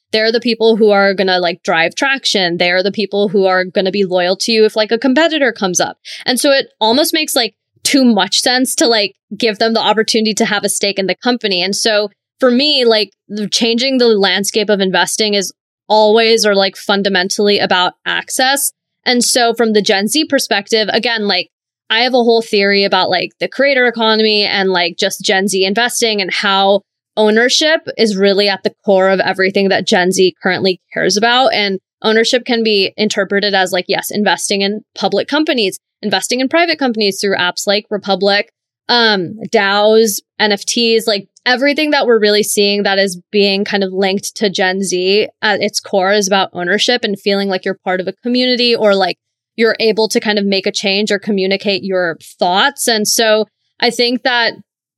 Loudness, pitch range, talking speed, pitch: -13 LUFS, 195-230 Hz, 195 wpm, 210 Hz